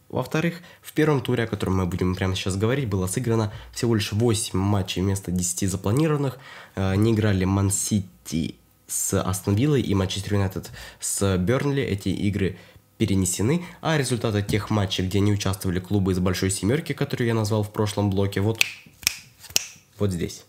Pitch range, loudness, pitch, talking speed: 95-115 Hz, -24 LUFS, 100 Hz, 160 wpm